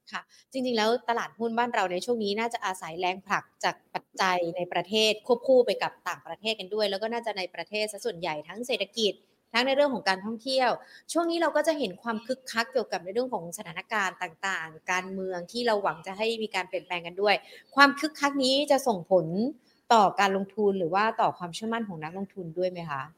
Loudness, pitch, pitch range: -28 LUFS, 210 Hz, 185-235 Hz